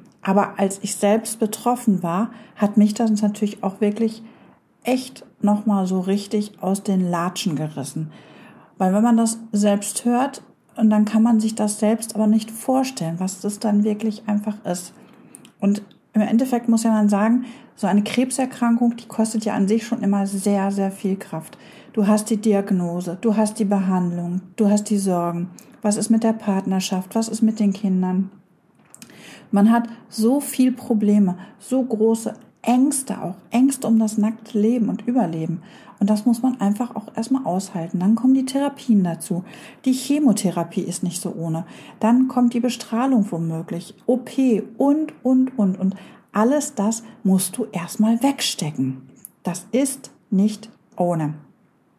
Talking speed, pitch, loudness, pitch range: 160 wpm, 215 Hz, -21 LUFS, 195-235 Hz